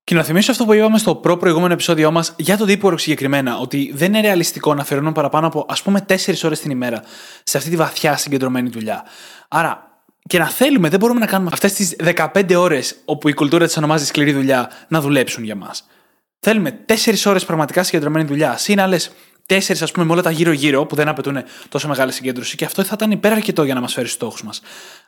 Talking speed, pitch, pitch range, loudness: 220 wpm, 165 Hz, 145-190 Hz, -16 LUFS